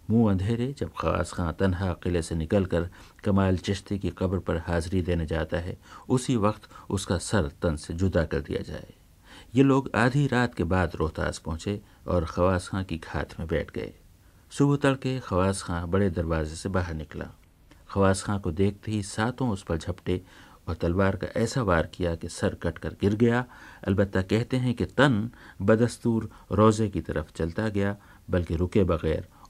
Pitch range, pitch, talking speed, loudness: 85-105 Hz, 95 Hz, 180 wpm, -27 LUFS